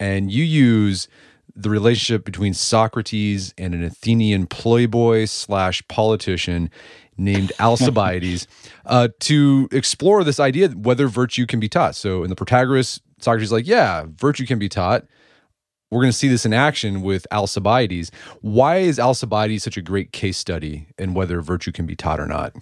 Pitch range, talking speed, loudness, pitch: 95-125 Hz, 165 wpm, -19 LUFS, 110 Hz